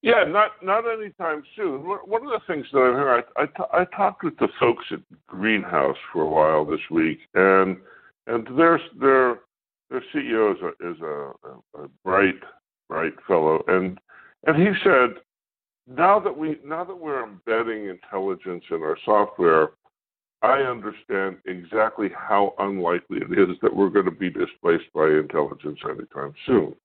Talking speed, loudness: 165 wpm, -22 LUFS